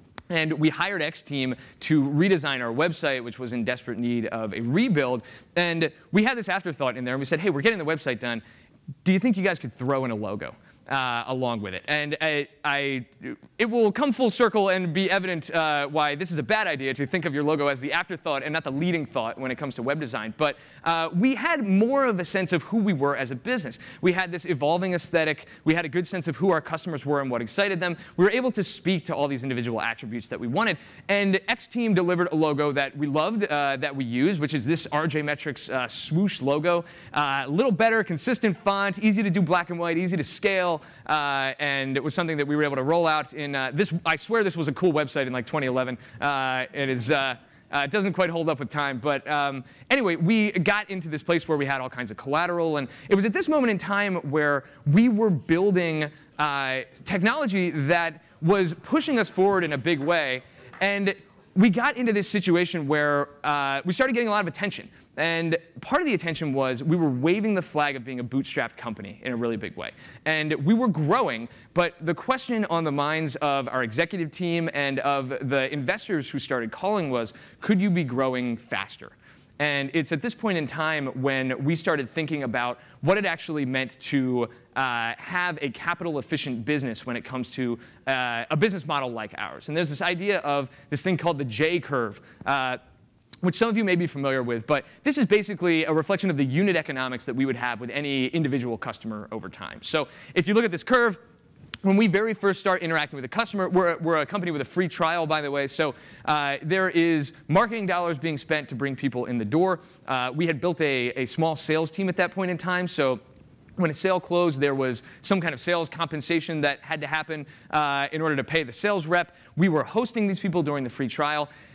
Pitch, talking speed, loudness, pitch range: 155 Hz, 230 wpm, -25 LUFS, 135-180 Hz